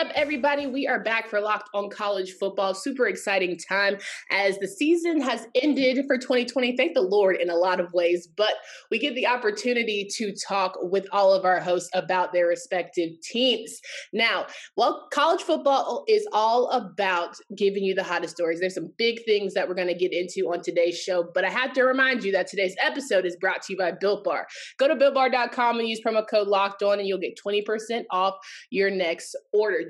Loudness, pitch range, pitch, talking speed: -24 LUFS, 185-250 Hz, 200 Hz, 205 wpm